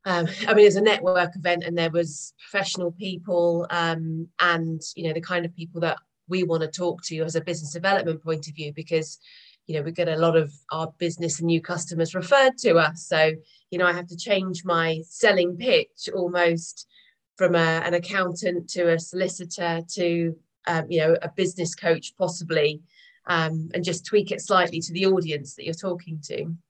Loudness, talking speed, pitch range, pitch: -24 LUFS, 200 wpm, 165-180 Hz, 170 Hz